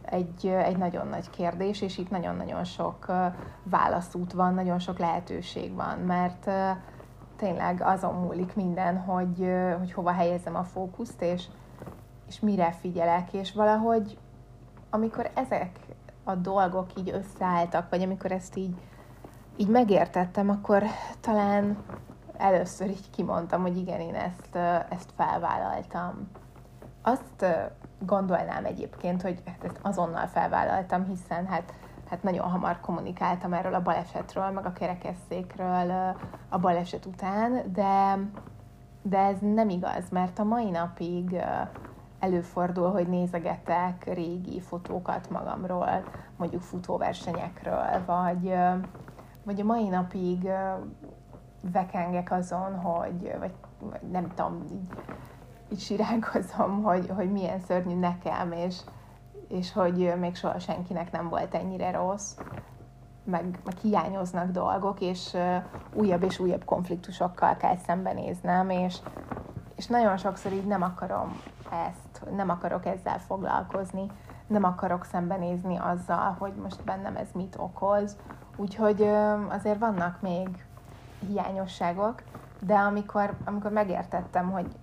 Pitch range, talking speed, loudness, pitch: 175-195 Hz, 120 wpm, -29 LUFS, 185 Hz